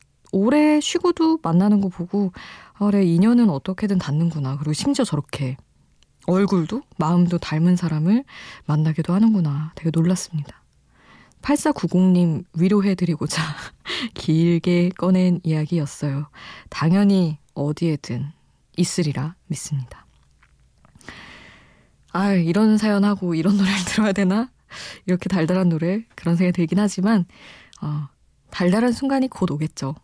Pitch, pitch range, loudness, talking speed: 175 Hz, 155-200 Hz, -21 LUFS, 280 characters per minute